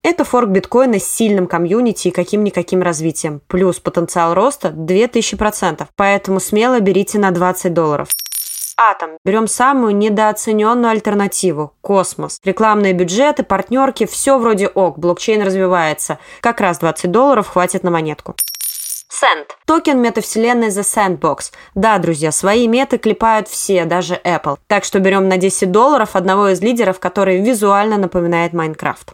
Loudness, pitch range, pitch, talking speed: -14 LUFS, 180-220 Hz, 195 Hz, 135 wpm